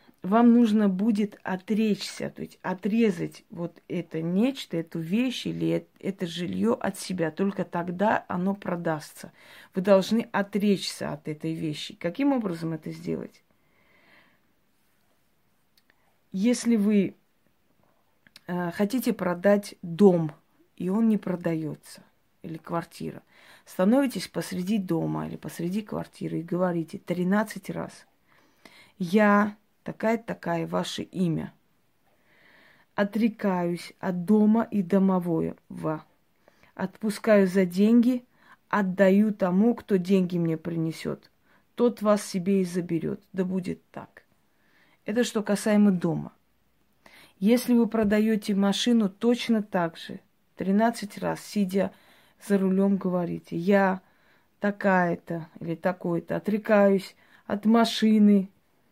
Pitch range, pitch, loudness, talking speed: 175-215 Hz, 195 Hz, -26 LUFS, 105 wpm